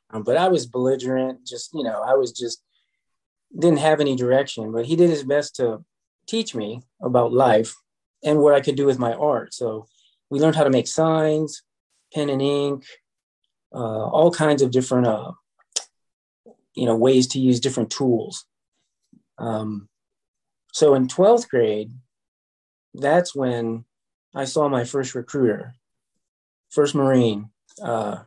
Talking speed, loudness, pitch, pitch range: 150 wpm, -21 LUFS, 130 Hz, 115-145 Hz